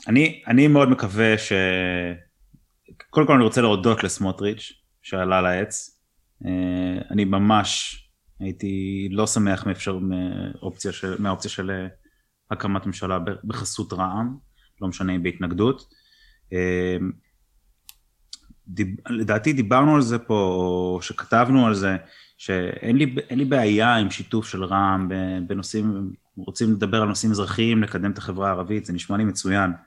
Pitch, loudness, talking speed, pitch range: 100 Hz, -22 LUFS, 125 wpm, 95-110 Hz